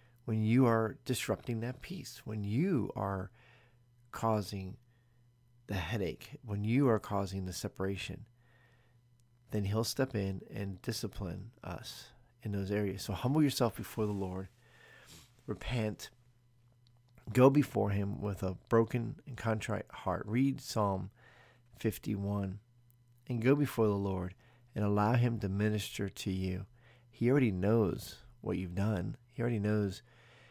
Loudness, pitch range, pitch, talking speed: -34 LUFS, 100-120 Hz, 115 Hz, 135 wpm